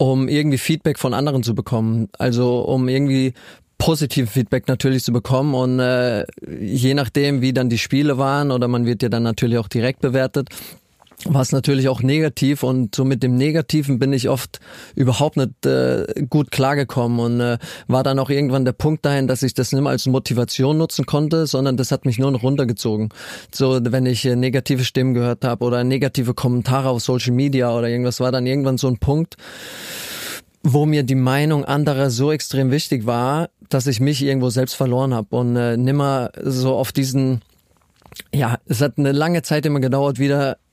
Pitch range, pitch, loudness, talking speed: 125-140 Hz, 130 Hz, -19 LUFS, 190 wpm